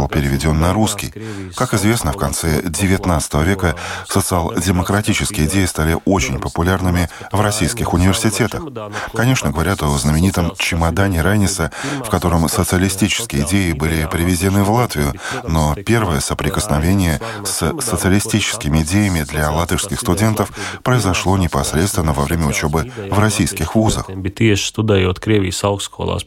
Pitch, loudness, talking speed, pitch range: 95 Hz, -17 LUFS, 110 wpm, 80-105 Hz